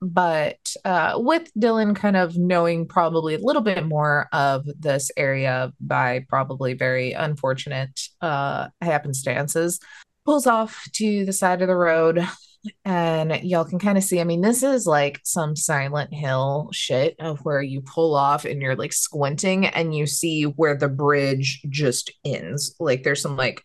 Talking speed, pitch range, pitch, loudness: 165 wpm, 140-180 Hz, 155 Hz, -22 LUFS